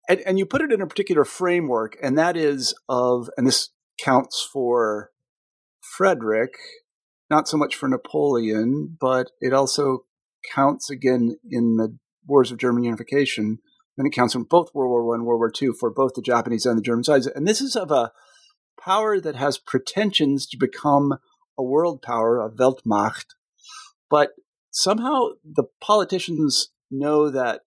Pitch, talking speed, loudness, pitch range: 140 Hz, 165 wpm, -22 LUFS, 120-190 Hz